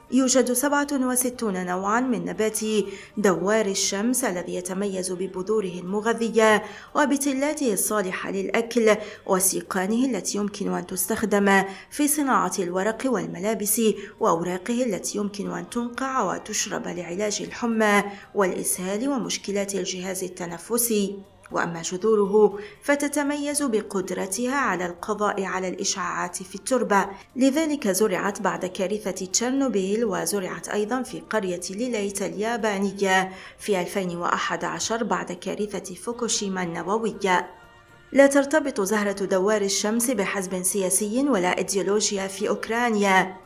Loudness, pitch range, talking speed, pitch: -24 LUFS, 190-230 Hz, 100 wpm, 205 Hz